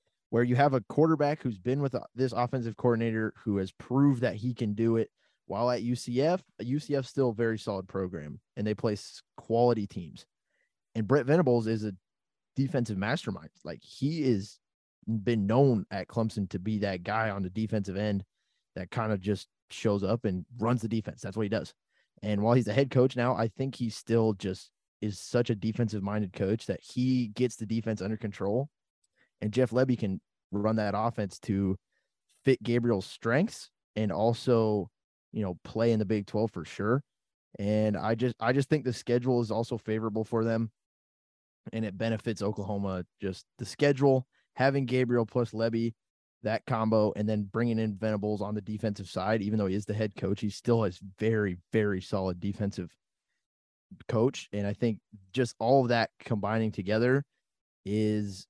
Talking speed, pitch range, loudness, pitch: 180 wpm, 105-120 Hz, -30 LUFS, 110 Hz